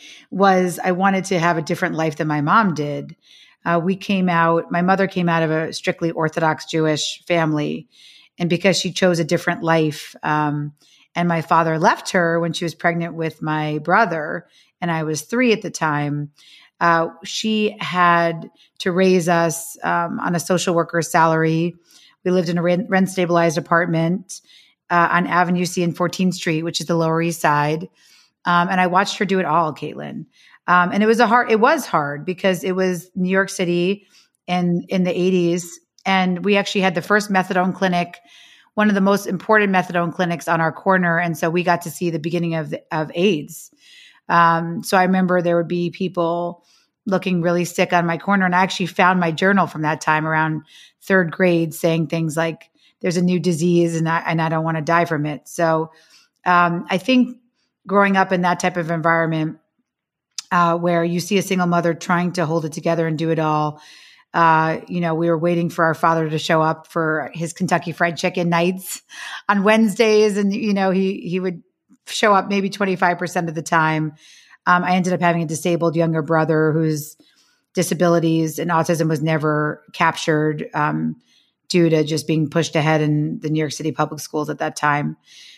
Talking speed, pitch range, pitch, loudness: 195 wpm, 160-185 Hz, 170 Hz, -19 LUFS